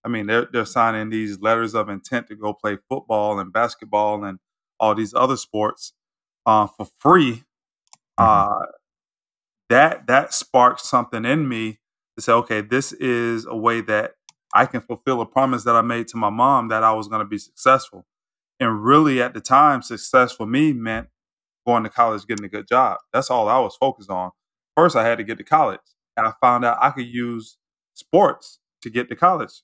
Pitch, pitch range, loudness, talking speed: 115 Hz, 110-120 Hz, -19 LUFS, 195 wpm